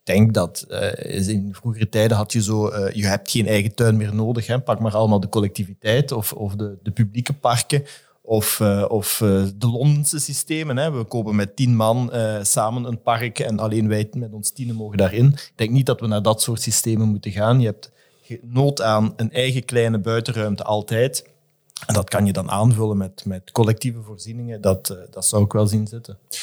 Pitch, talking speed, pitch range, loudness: 110 Hz, 210 wpm, 105-120 Hz, -20 LUFS